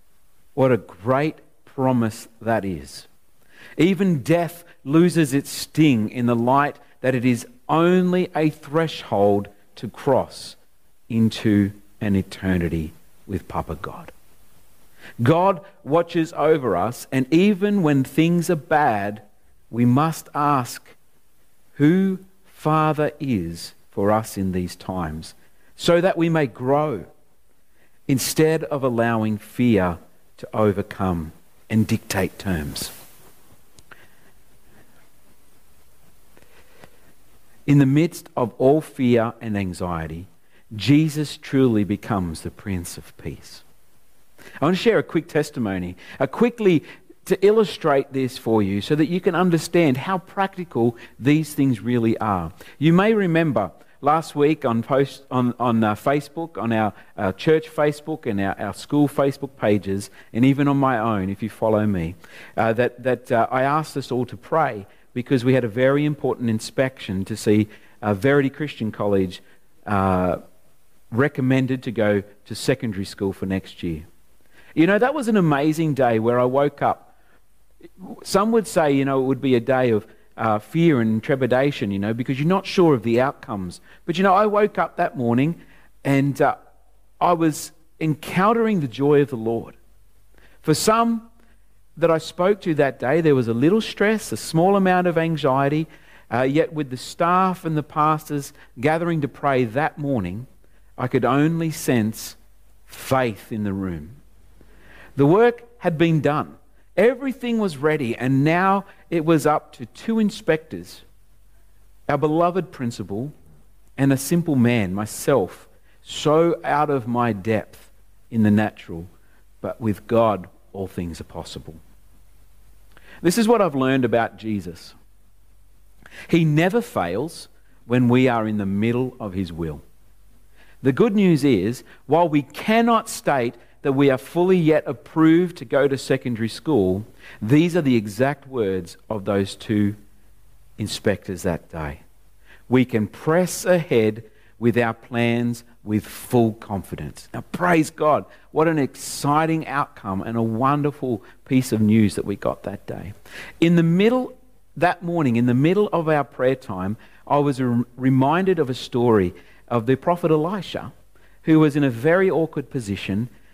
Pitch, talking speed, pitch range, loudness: 130 Hz, 150 wpm, 105-155 Hz, -21 LUFS